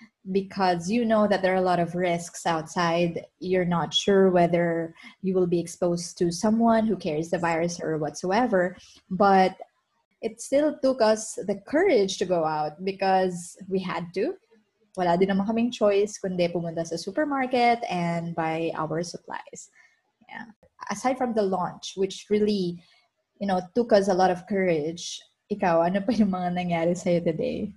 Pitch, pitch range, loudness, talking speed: 190 Hz, 175-215 Hz, -25 LUFS, 155 wpm